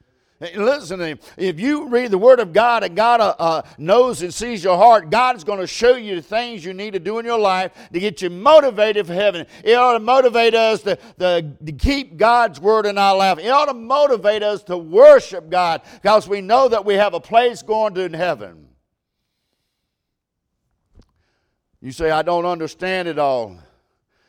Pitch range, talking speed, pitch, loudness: 175-235 Hz, 200 wpm, 205 Hz, -16 LUFS